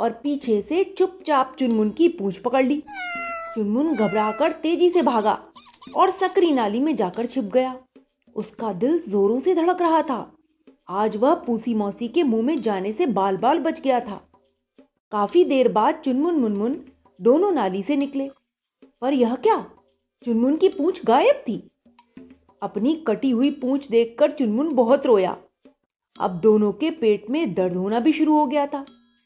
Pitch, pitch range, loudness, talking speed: 260 Hz, 220-310 Hz, -21 LUFS, 160 wpm